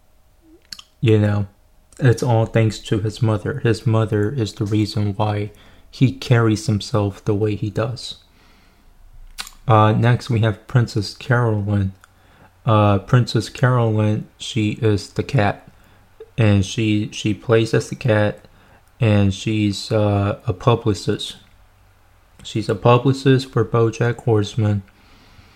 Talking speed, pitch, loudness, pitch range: 120 wpm, 110 Hz, -19 LUFS, 100-115 Hz